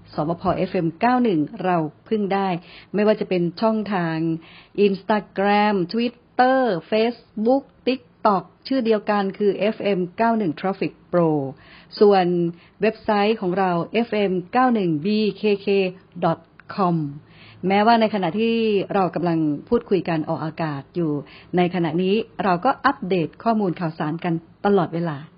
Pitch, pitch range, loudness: 190 Hz, 170-215 Hz, -21 LUFS